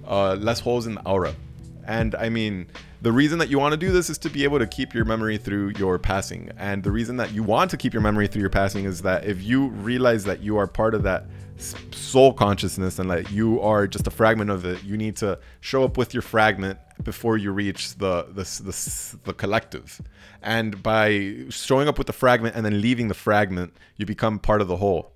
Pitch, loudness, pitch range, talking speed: 105 Hz, -23 LUFS, 100-120 Hz, 230 wpm